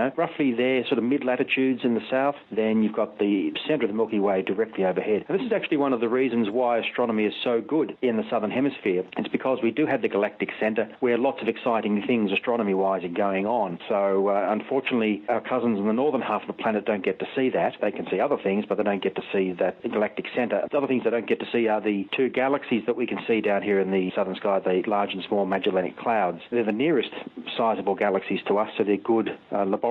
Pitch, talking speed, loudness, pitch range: 115 Hz, 255 wpm, -25 LUFS, 100-130 Hz